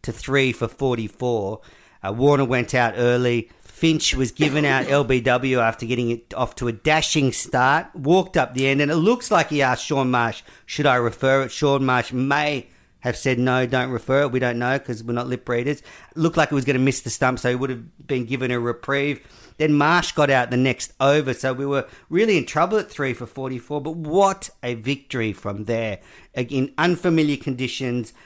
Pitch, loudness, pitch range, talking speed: 130 Hz, -21 LUFS, 120-145 Hz, 210 wpm